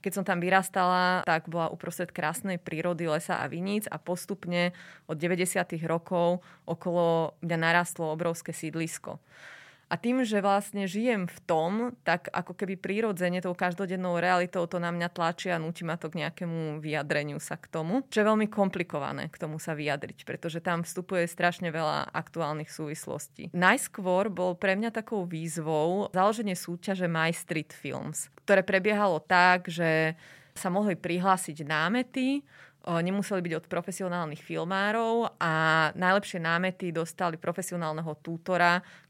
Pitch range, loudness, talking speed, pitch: 165-190 Hz, -29 LUFS, 145 wpm, 175 Hz